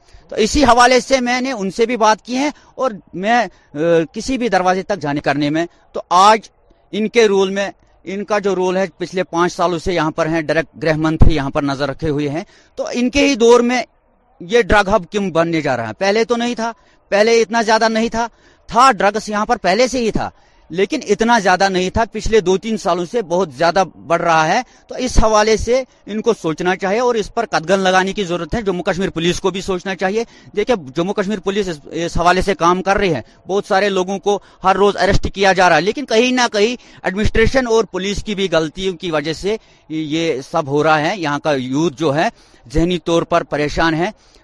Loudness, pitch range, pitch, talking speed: -16 LUFS, 165-220 Hz, 195 Hz, 225 wpm